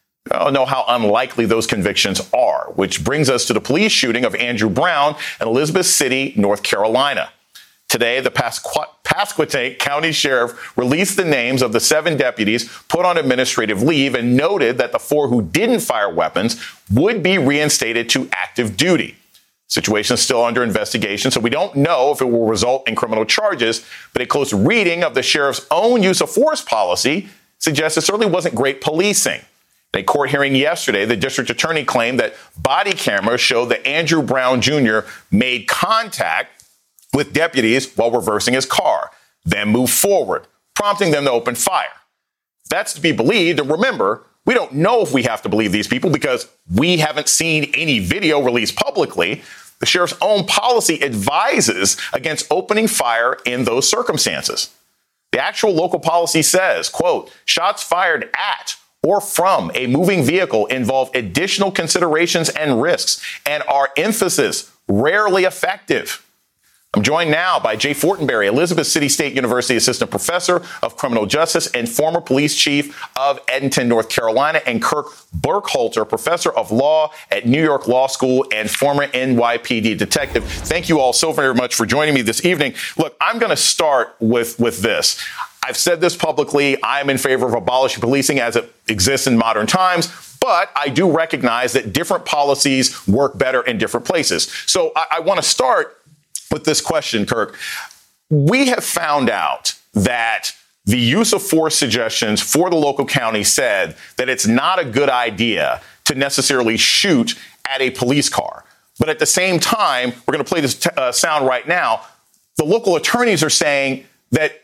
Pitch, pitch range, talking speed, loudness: 140 Hz, 125-165 Hz, 170 wpm, -16 LUFS